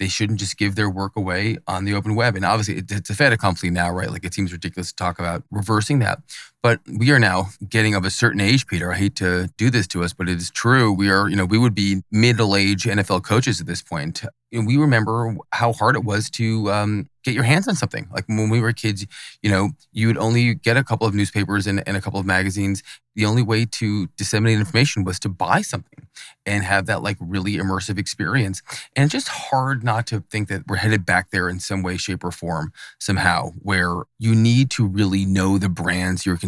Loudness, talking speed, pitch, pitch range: -20 LUFS, 235 wpm, 105 Hz, 95-115 Hz